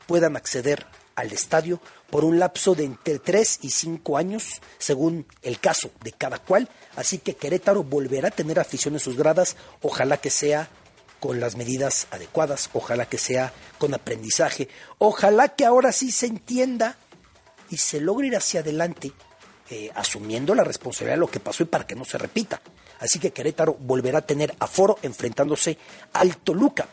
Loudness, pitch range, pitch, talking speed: -22 LUFS, 145-200 Hz, 165 Hz, 170 wpm